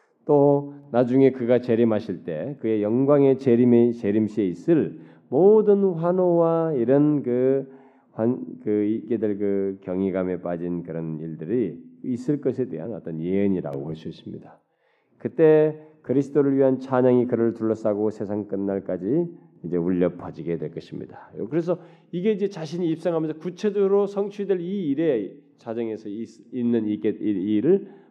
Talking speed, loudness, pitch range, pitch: 305 characters per minute, -23 LUFS, 105-155 Hz, 125 Hz